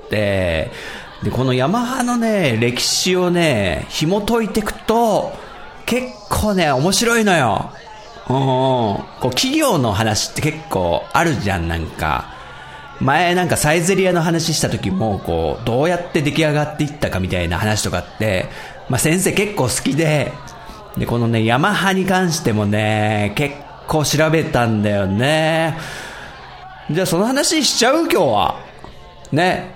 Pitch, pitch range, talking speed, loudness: 150 Hz, 110-185 Hz, 270 characters per minute, -17 LUFS